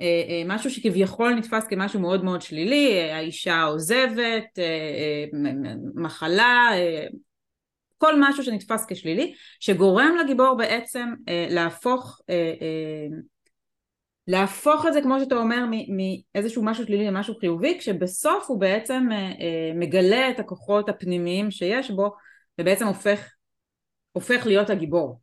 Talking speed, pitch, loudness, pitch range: 100 wpm, 200 Hz, -23 LUFS, 175-240 Hz